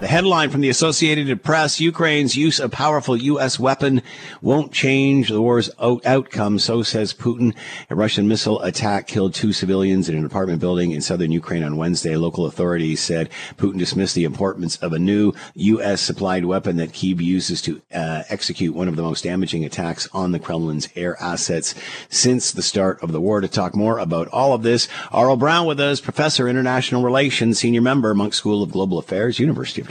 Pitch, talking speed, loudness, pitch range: 105 Hz, 195 wpm, -19 LUFS, 90-130 Hz